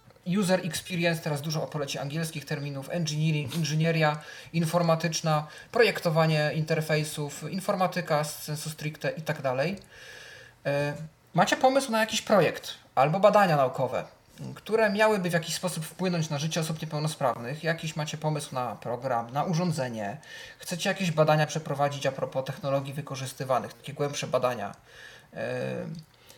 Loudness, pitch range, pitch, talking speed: -28 LUFS, 145-170 Hz, 155 Hz, 120 wpm